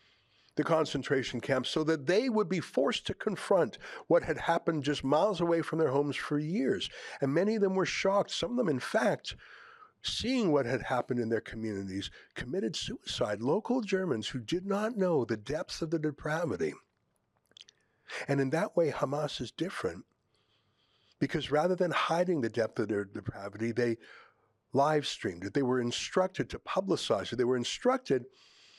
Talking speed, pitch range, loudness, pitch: 170 wpm, 125-180 Hz, -31 LUFS, 150 Hz